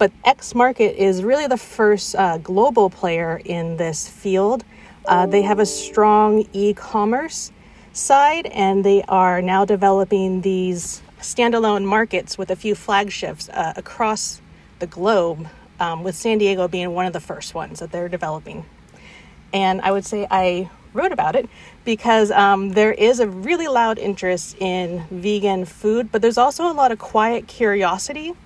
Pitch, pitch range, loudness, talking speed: 200 Hz, 185-220 Hz, -19 LUFS, 160 wpm